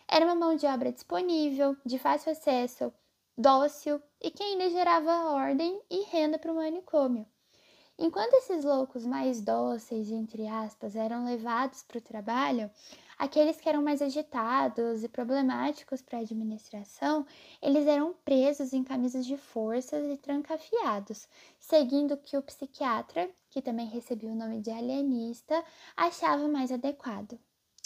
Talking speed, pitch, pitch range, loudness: 140 wpm, 280 Hz, 240-310 Hz, -30 LUFS